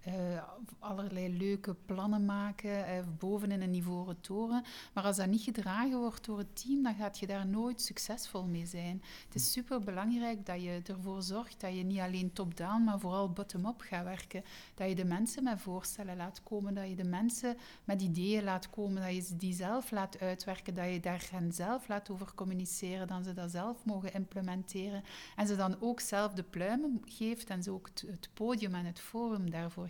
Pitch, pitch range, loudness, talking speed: 195 Hz, 185-215 Hz, -38 LUFS, 200 wpm